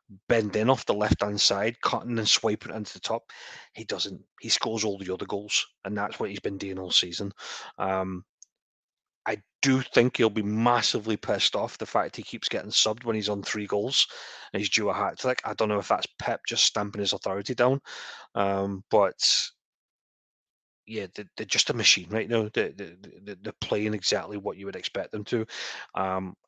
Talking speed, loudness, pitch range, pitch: 195 wpm, -27 LUFS, 100-115 Hz, 105 Hz